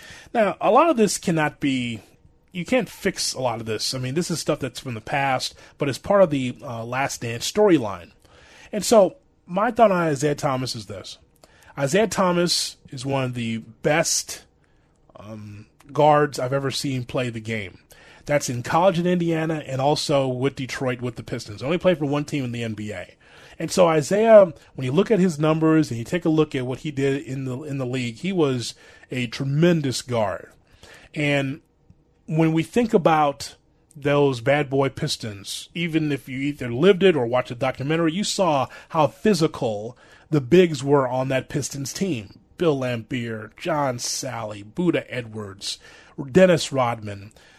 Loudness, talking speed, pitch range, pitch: -22 LUFS, 180 wpm, 125-160 Hz, 140 Hz